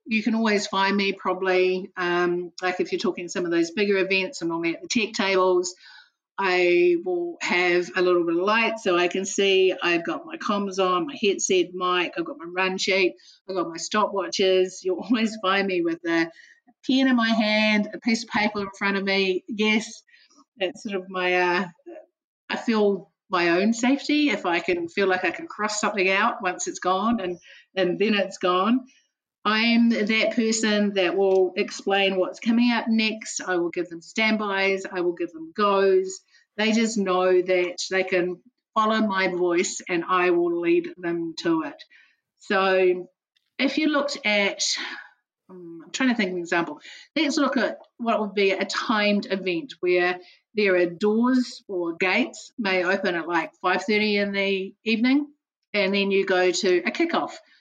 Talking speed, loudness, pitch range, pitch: 185 wpm, -23 LUFS, 180-230 Hz, 195 Hz